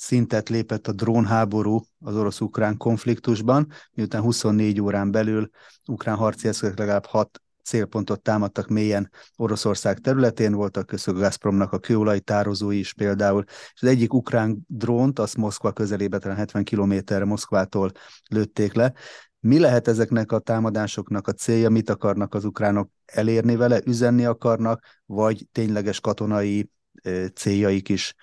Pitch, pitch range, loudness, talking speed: 110 Hz, 100-115 Hz, -23 LUFS, 135 wpm